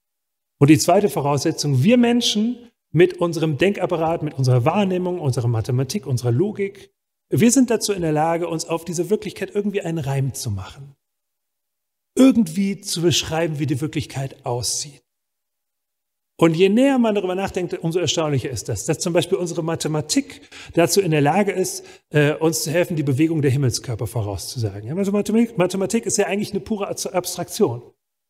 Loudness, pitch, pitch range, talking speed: -20 LUFS, 170 Hz, 145-200 Hz, 155 wpm